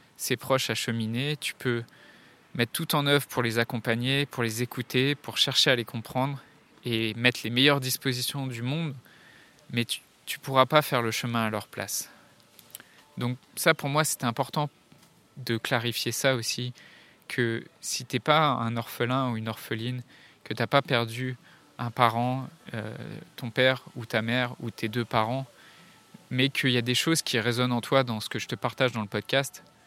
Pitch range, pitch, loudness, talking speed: 120-135 Hz, 125 Hz, -27 LUFS, 190 wpm